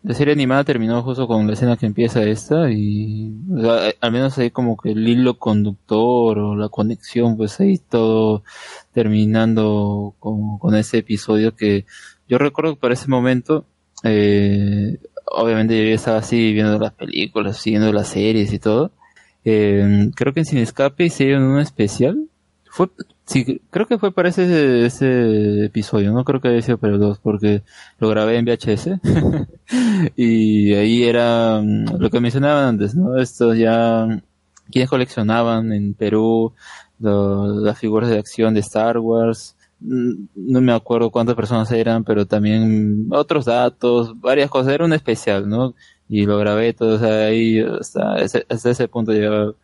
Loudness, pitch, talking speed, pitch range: -17 LUFS, 115 Hz, 165 wpm, 105-125 Hz